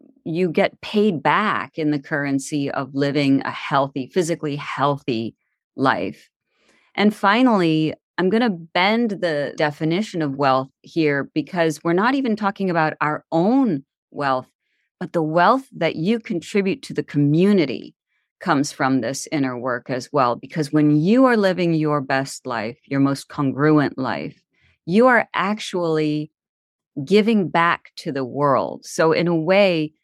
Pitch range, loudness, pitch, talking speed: 140-190 Hz, -20 LUFS, 155 Hz, 150 wpm